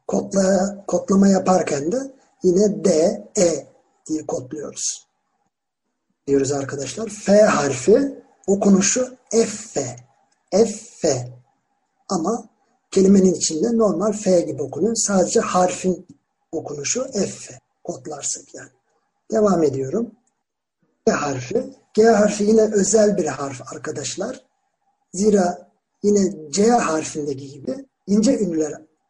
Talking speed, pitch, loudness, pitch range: 105 wpm, 195 Hz, -20 LUFS, 155-225 Hz